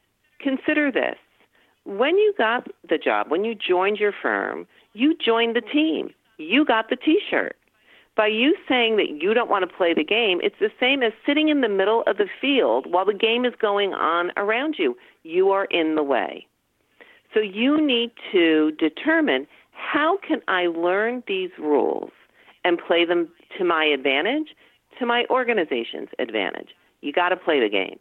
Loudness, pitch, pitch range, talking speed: -22 LUFS, 250 Hz, 205-325 Hz, 175 wpm